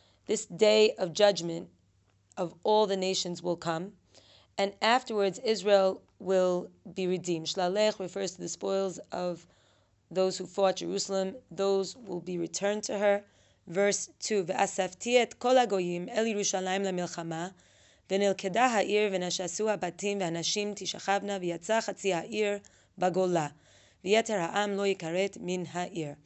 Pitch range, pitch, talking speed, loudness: 175-205 Hz, 190 Hz, 125 wpm, -30 LUFS